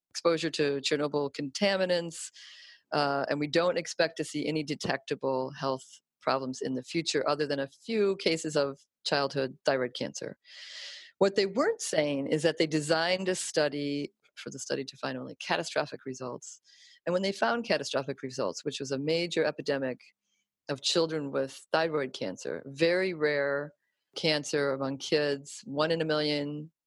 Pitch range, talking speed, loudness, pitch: 140-170 Hz, 155 wpm, -30 LUFS, 150 Hz